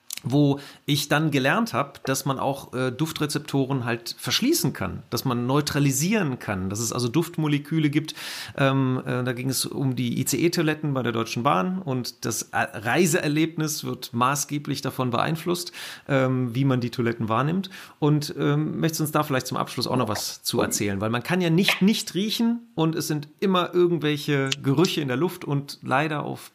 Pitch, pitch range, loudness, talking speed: 145 Hz, 130-160 Hz, -24 LUFS, 180 wpm